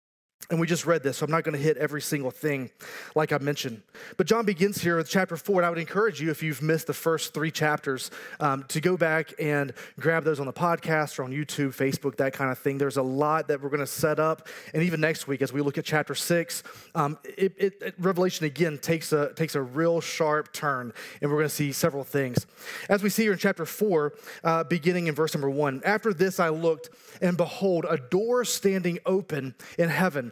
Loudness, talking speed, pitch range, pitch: -27 LUFS, 235 wpm, 145-175 Hz, 160 Hz